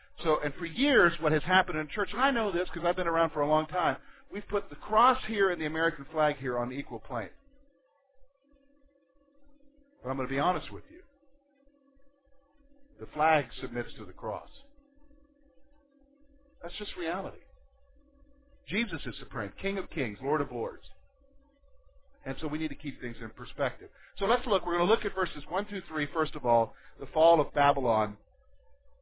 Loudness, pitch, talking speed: -30 LUFS, 195 Hz, 185 wpm